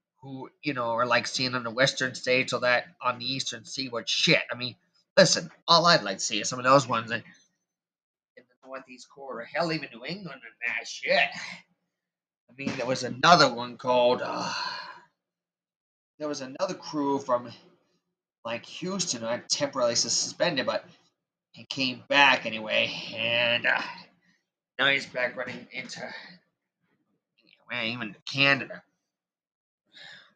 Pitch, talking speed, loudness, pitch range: 130 Hz, 150 wpm, -26 LUFS, 120-140 Hz